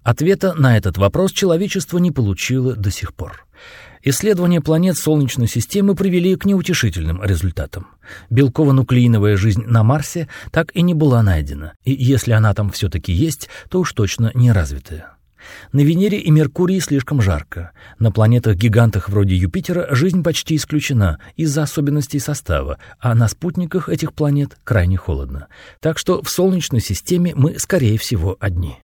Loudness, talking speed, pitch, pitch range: -17 LUFS, 145 wpm, 125 Hz, 100-160 Hz